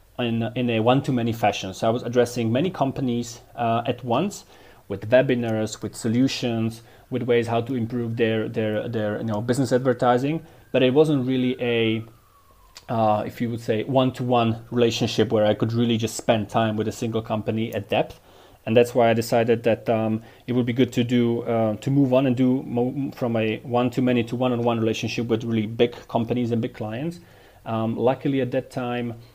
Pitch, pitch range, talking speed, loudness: 120 Hz, 110-125 Hz, 190 wpm, -23 LUFS